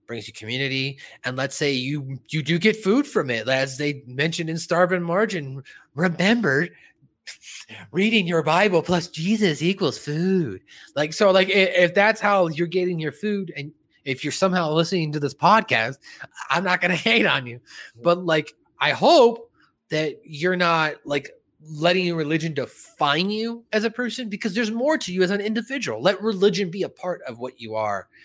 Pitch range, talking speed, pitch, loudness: 145-200 Hz, 180 wpm, 175 Hz, -22 LUFS